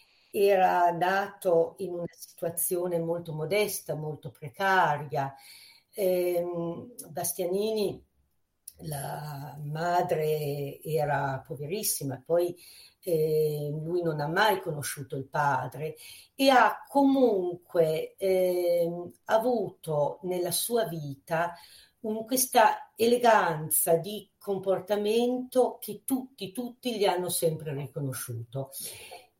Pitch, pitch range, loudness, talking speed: 175 Hz, 155-200 Hz, -28 LUFS, 90 wpm